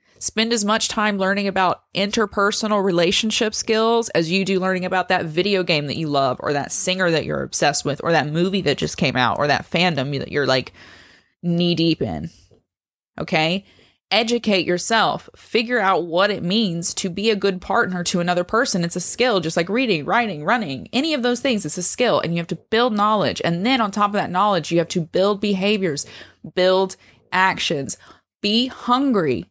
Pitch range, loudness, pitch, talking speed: 170-215 Hz, -19 LUFS, 190 Hz, 195 wpm